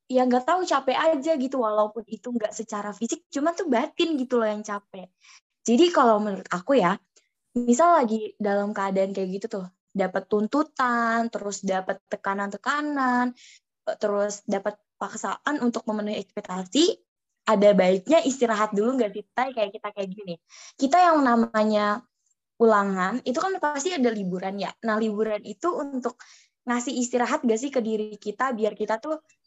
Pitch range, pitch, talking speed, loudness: 205-265 Hz, 225 Hz, 155 wpm, -25 LUFS